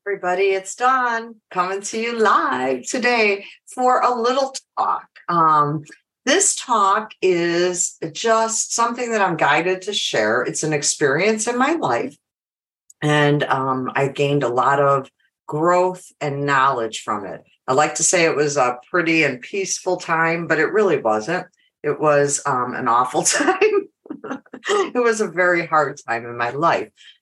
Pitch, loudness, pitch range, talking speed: 180 Hz, -19 LUFS, 145-225 Hz, 155 wpm